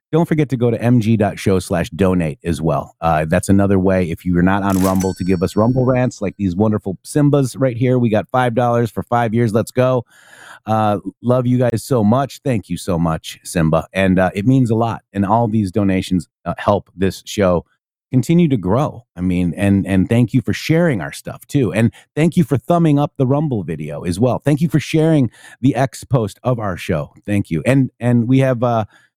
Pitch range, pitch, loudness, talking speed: 95-130 Hz, 115 Hz, -17 LUFS, 220 wpm